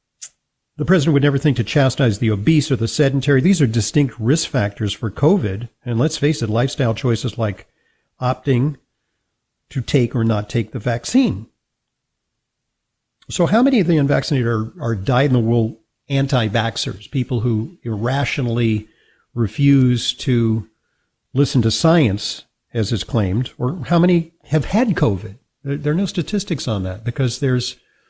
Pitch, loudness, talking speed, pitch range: 125 Hz, -18 LUFS, 145 wpm, 115-145 Hz